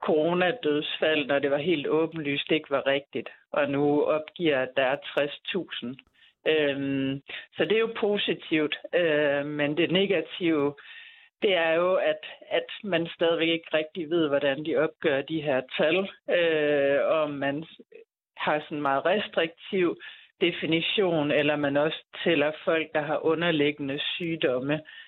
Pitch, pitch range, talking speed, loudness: 155 Hz, 145-175 Hz, 145 wpm, -26 LUFS